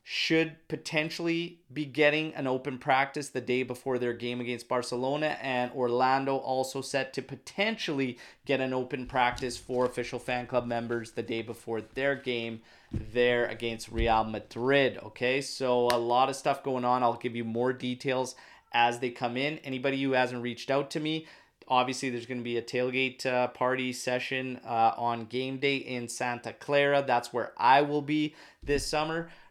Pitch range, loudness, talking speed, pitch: 120-140 Hz, -30 LUFS, 175 wpm, 130 Hz